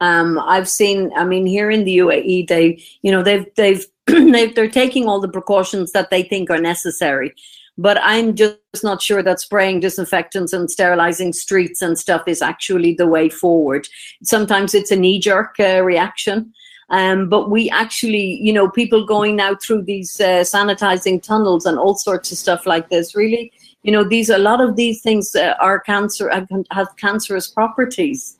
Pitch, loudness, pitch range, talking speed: 195 Hz, -15 LUFS, 185-215 Hz, 180 wpm